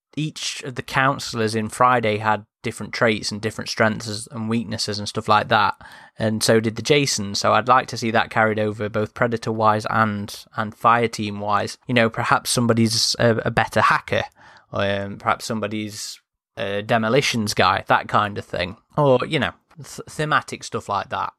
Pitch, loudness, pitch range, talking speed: 110 Hz, -21 LUFS, 105-120 Hz, 185 wpm